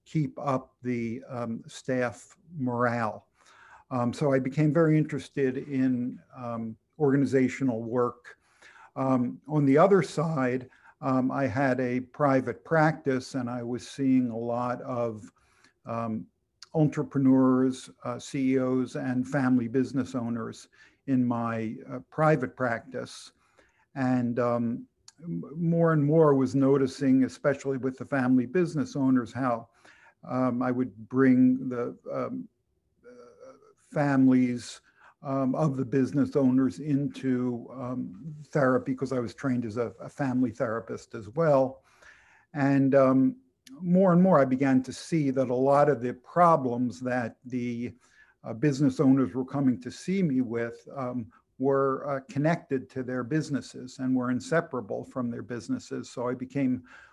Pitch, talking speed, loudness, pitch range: 130 Hz, 135 wpm, -27 LUFS, 125-140 Hz